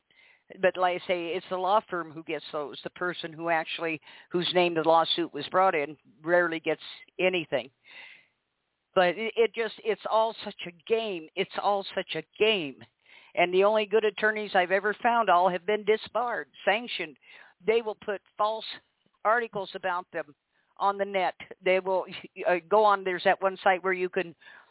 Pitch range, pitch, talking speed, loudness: 170-210 Hz, 185 Hz, 175 wpm, -27 LUFS